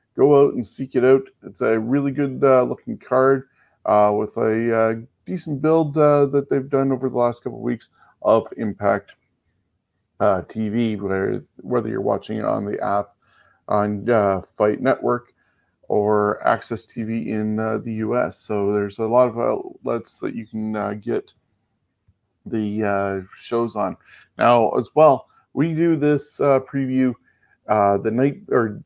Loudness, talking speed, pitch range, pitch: -21 LUFS, 160 wpm, 105-135 Hz, 115 Hz